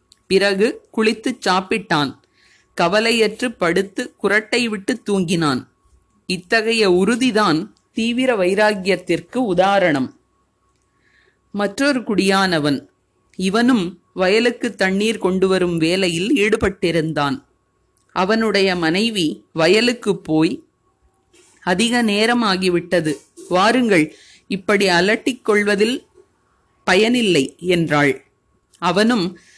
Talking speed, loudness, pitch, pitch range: 70 wpm, -18 LUFS, 200 Hz, 175-230 Hz